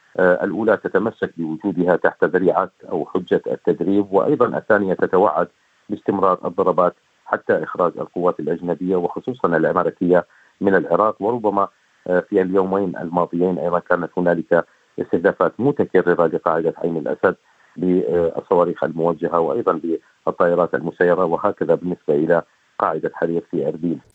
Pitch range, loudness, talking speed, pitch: 85-95 Hz, -20 LUFS, 110 wpm, 90 Hz